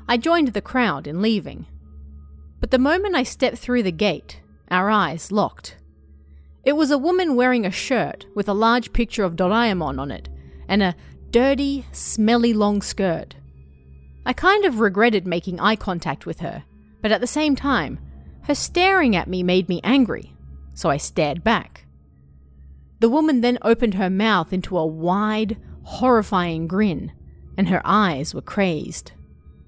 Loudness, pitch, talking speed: -20 LUFS, 190 Hz, 160 wpm